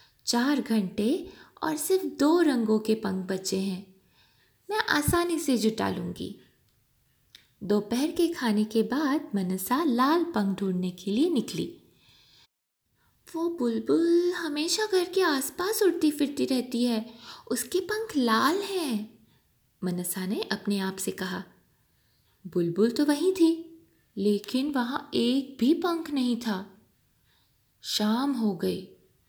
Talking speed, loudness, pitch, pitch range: 125 wpm, -27 LUFS, 255 Hz, 210-330 Hz